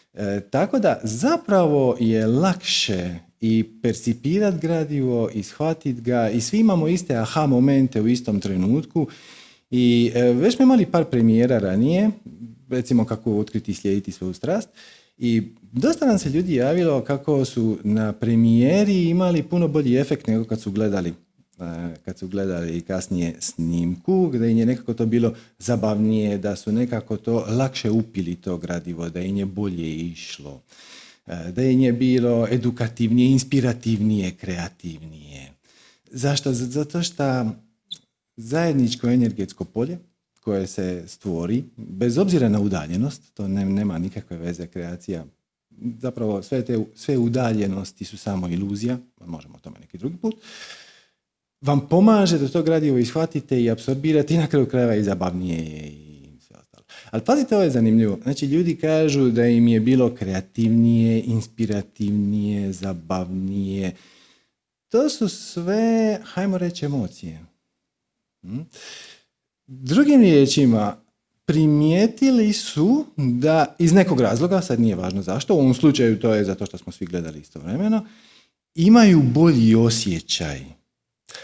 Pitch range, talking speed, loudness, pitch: 100-150 Hz, 135 wpm, -21 LUFS, 115 Hz